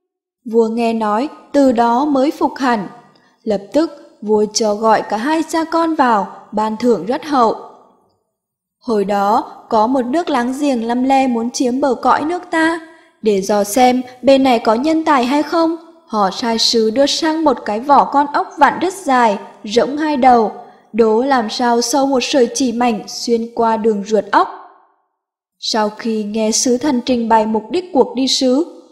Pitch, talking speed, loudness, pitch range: 245 Hz, 185 wpm, -15 LUFS, 225-290 Hz